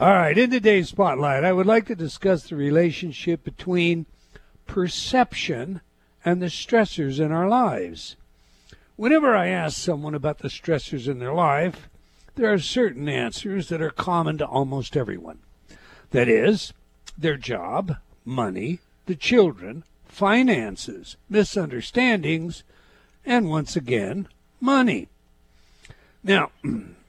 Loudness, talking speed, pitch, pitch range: -23 LUFS, 115 wpm, 170 Hz, 145-195 Hz